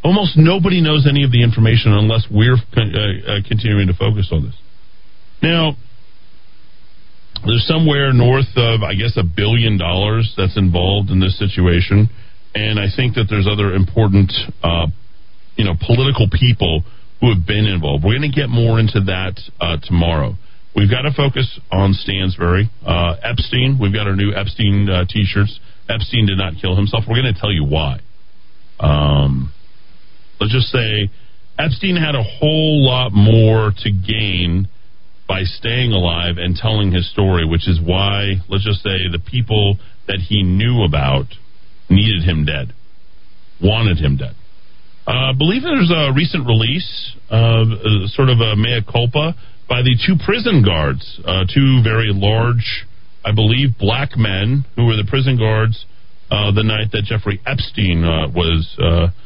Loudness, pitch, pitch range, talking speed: -15 LUFS, 105 Hz, 95-120 Hz, 160 wpm